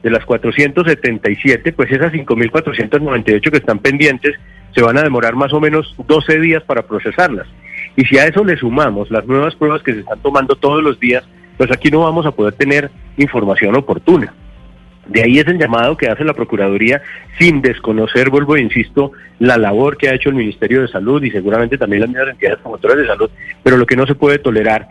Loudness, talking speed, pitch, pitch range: -13 LUFS, 200 wpm, 135 Hz, 115-150 Hz